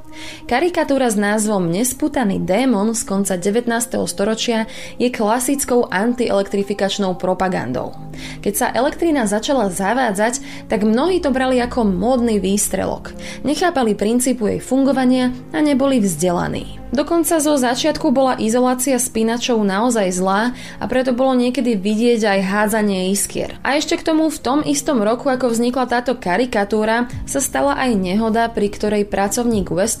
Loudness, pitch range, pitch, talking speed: -18 LUFS, 205-260 Hz, 235 Hz, 135 wpm